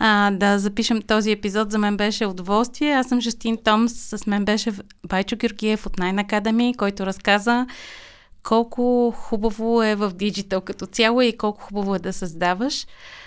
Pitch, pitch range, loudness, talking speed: 215 Hz, 200-235 Hz, -21 LUFS, 165 wpm